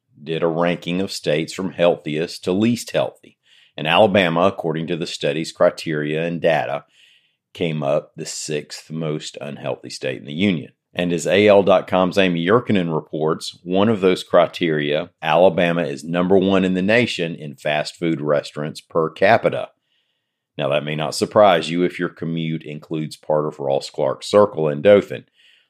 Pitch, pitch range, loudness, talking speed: 85 Hz, 75-95 Hz, -19 LUFS, 160 wpm